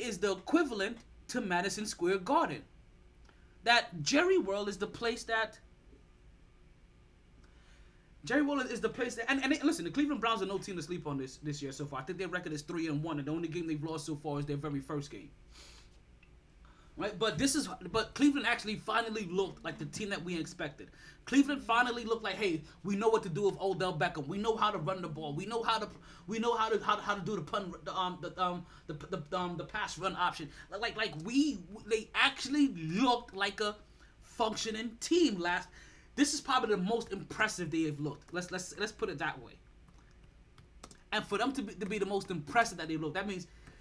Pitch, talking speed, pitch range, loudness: 195 Hz, 220 wpm, 160-225 Hz, -34 LUFS